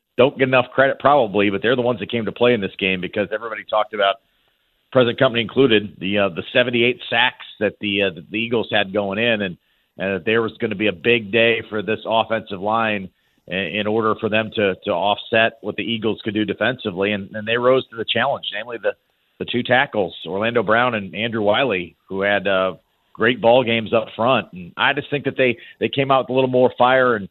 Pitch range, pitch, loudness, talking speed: 100-125 Hz, 110 Hz, -19 LUFS, 235 wpm